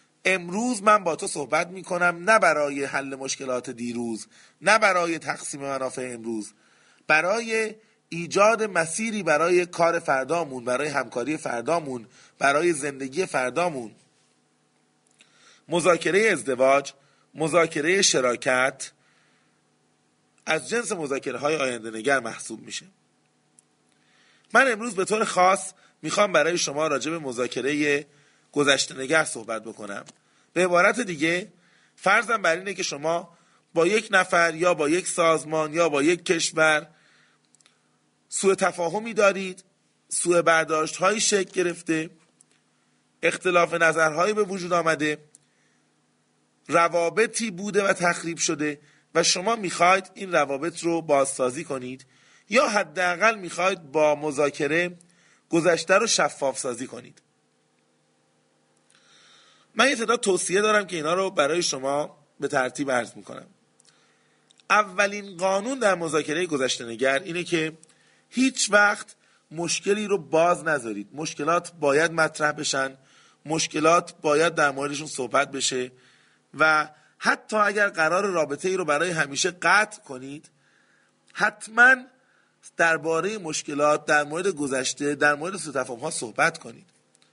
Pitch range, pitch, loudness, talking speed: 135-185 Hz, 160 Hz, -23 LUFS, 120 wpm